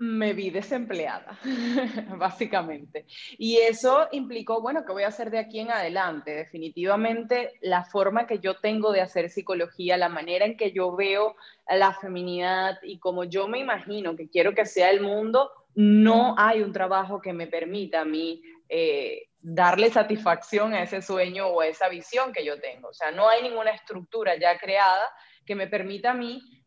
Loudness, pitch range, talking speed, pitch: -25 LUFS, 180-230 Hz, 180 wpm, 200 Hz